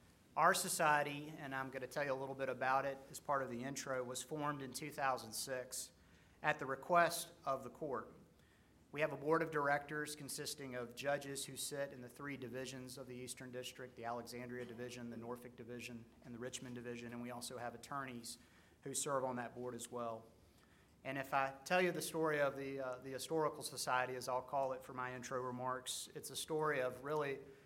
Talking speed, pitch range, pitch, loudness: 205 wpm, 125-145 Hz, 130 Hz, -42 LUFS